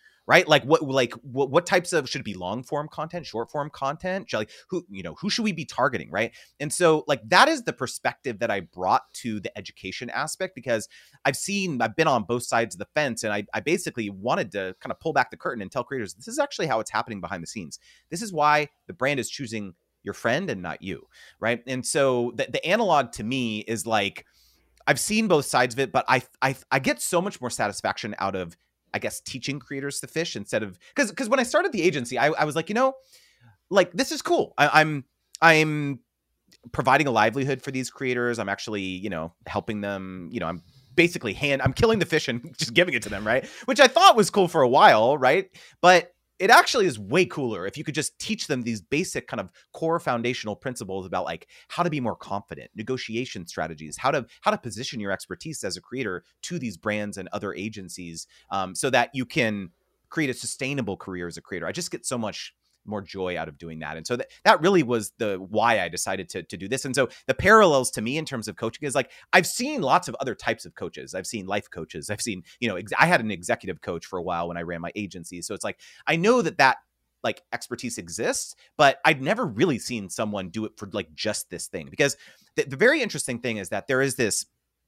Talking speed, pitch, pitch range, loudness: 240 wpm, 125 Hz, 105-155 Hz, -24 LUFS